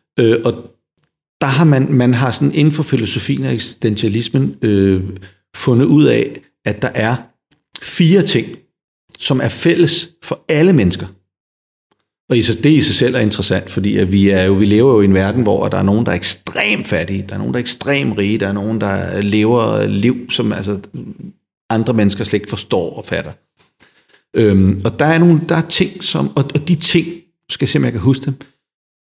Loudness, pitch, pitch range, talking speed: -14 LUFS, 120 Hz, 100-145 Hz, 195 wpm